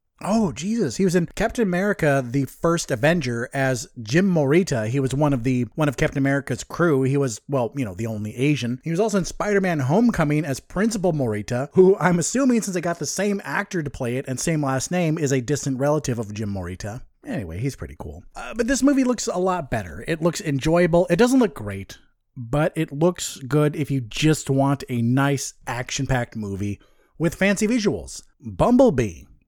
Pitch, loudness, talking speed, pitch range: 145 Hz, -22 LUFS, 200 wpm, 130-180 Hz